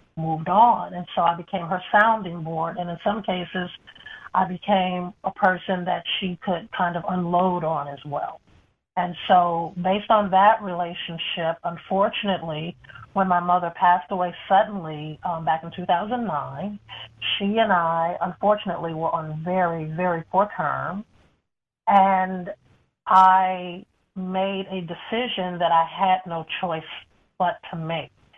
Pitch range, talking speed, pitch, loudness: 170-190 Hz, 140 wpm, 180 Hz, -23 LUFS